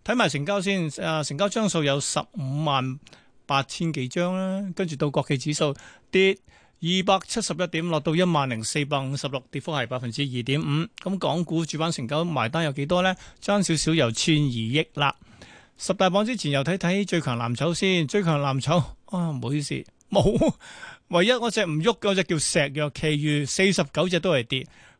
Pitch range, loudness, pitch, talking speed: 140-185 Hz, -24 LUFS, 160 Hz, 280 characters per minute